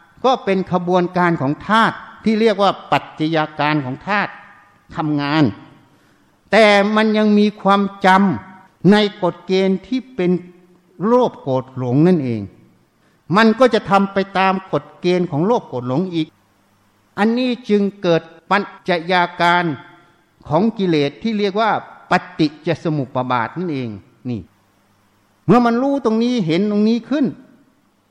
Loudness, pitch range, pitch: -17 LUFS, 150-205 Hz, 180 Hz